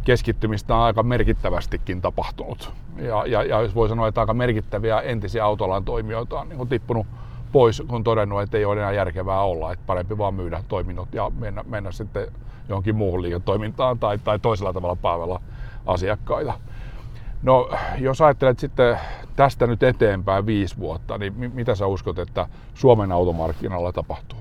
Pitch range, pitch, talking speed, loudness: 100-120 Hz, 110 Hz, 160 wpm, -22 LUFS